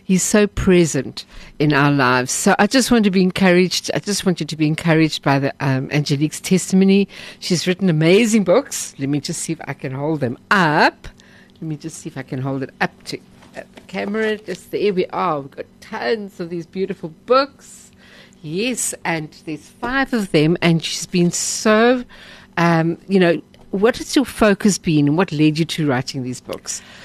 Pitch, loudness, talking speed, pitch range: 175 Hz, -18 LUFS, 200 wpm, 150-200 Hz